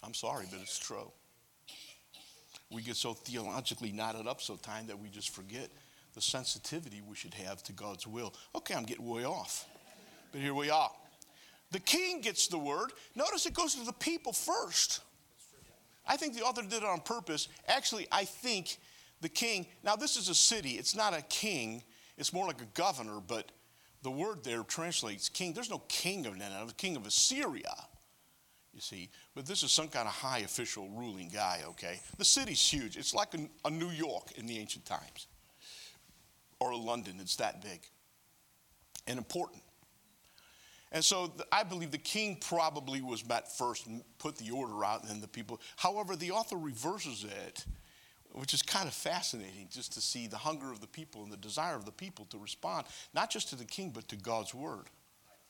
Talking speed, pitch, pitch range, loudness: 190 wpm, 145 Hz, 115-190 Hz, -35 LUFS